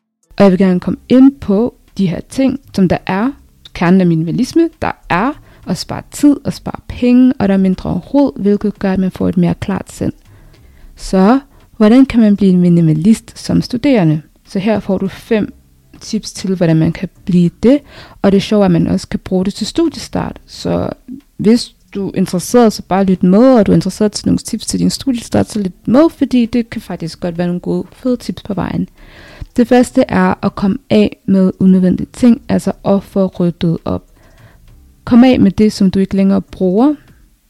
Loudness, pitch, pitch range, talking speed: -13 LUFS, 195 Hz, 180-240 Hz, 205 wpm